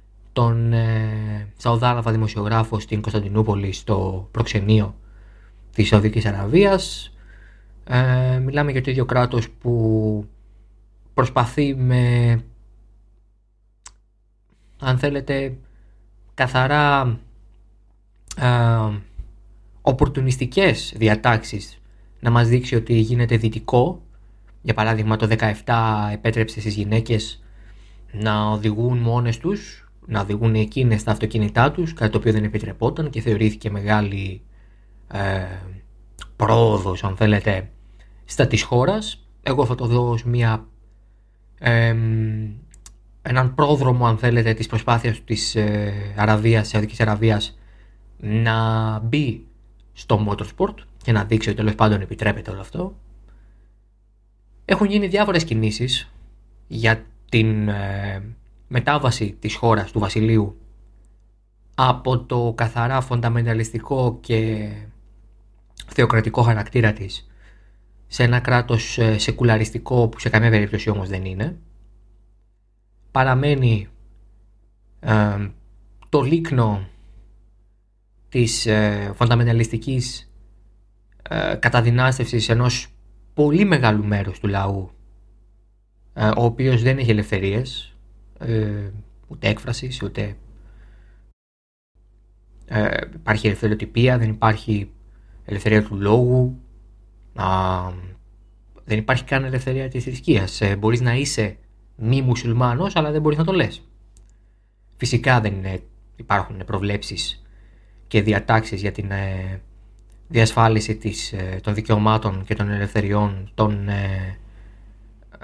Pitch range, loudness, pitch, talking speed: 105-120 Hz, -20 LUFS, 110 Hz, 105 wpm